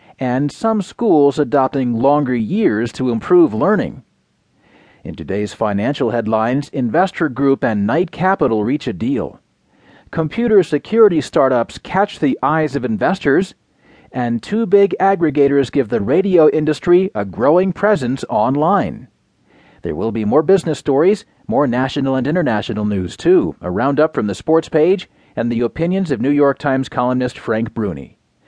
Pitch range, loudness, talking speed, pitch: 120-170 Hz, -16 LUFS, 145 wpm, 140 Hz